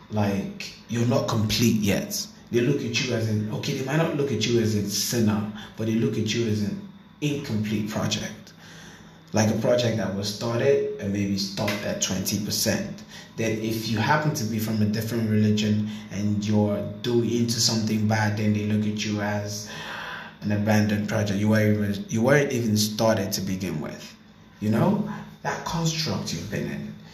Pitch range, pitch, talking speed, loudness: 105-120 Hz, 110 Hz, 185 wpm, -25 LUFS